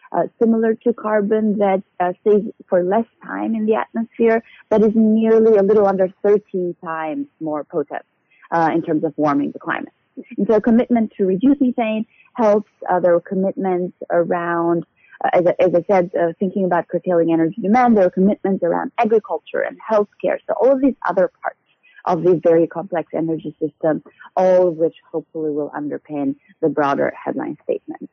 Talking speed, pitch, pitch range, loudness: 180 wpm, 190 Hz, 170-220 Hz, -18 LUFS